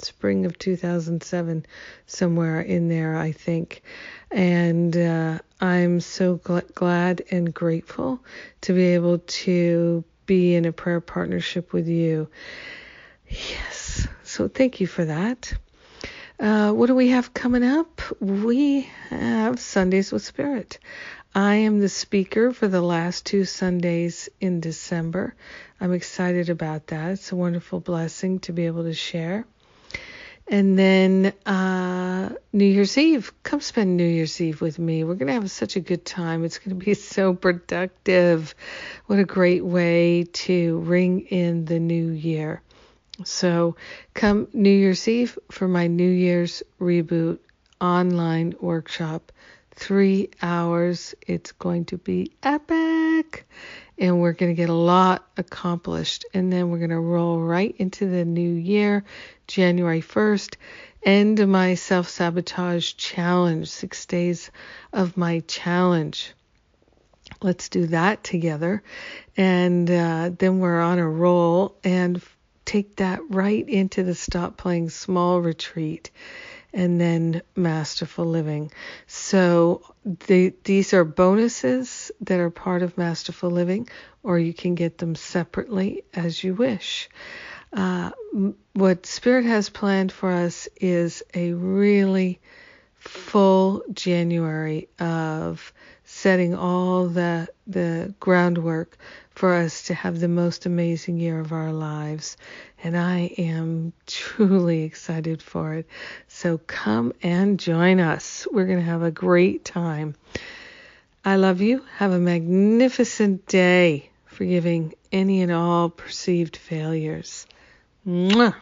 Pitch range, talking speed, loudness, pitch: 170-195 Hz, 130 wpm, -22 LUFS, 180 Hz